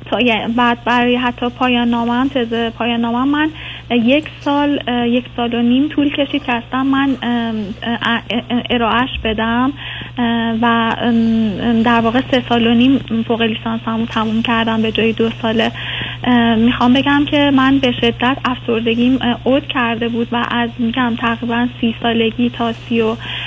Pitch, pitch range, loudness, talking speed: 235 Hz, 230-250 Hz, -15 LUFS, 140 wpm